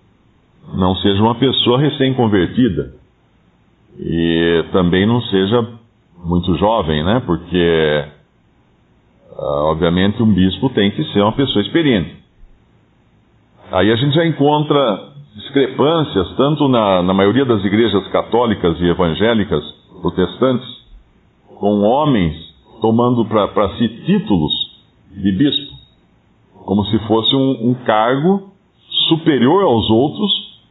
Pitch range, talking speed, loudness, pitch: 90-130 Hz, 105 wpm, -15 LUFS, 105 Hz